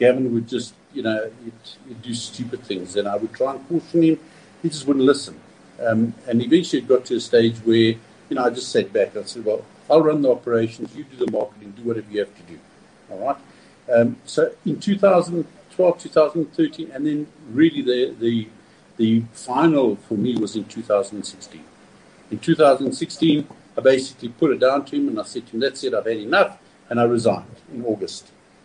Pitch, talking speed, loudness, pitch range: 130 Hz, 200 wpm, -21 LUFS, 115-175 Hz